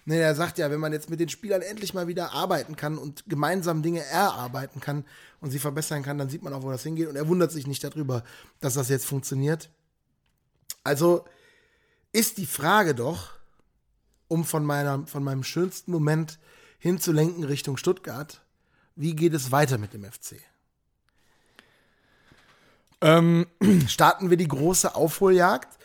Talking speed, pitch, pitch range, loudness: 160 wpm, 160 Hz, 145-175 Hz, -25 LUFS